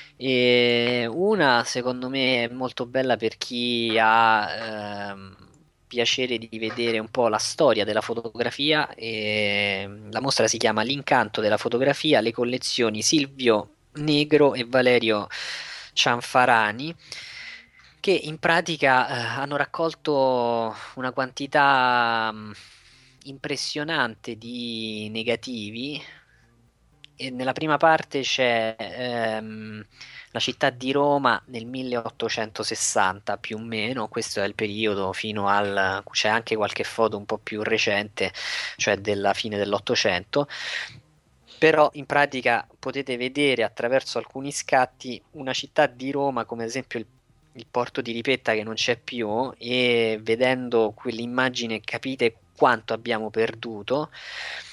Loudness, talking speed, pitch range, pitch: -24 LUFS, 120 wpm, 110-130 Hz, 120 Hz